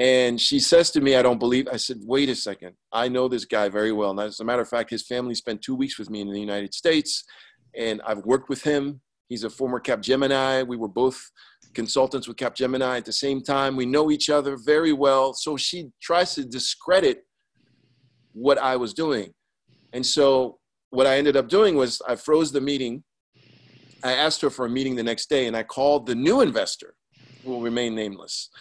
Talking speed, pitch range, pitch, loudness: 210 wpm, 120-140 Hz, 130 Hz, -23 LUFS